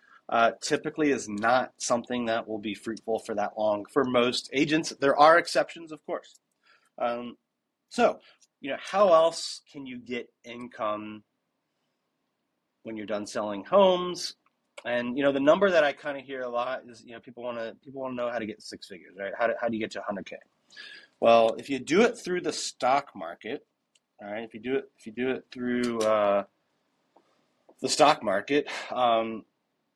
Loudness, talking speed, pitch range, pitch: -27 LUFS, 190 wpm, 110-140 Hz, 120 Hz